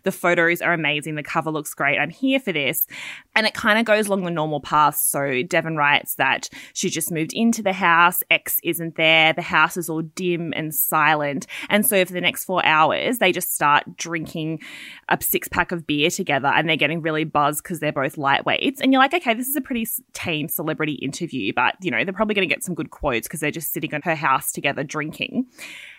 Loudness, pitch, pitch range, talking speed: -20 LUFS, 165 Hz, 150-190 Hz, 225 wpm